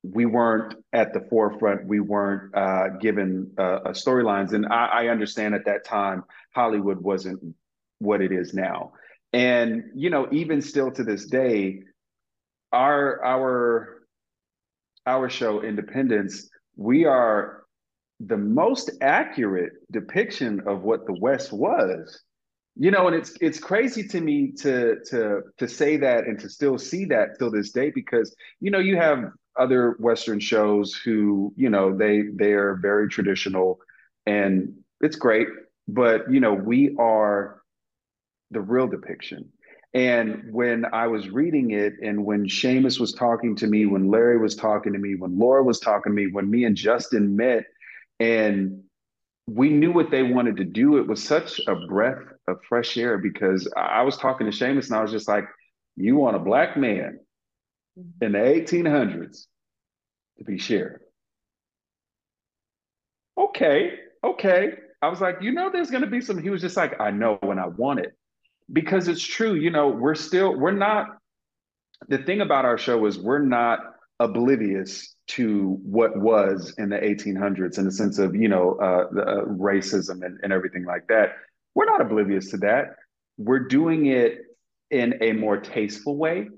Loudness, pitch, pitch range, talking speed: -23 LUFS, 115 Hz, 100-140 Hz, 165 wpm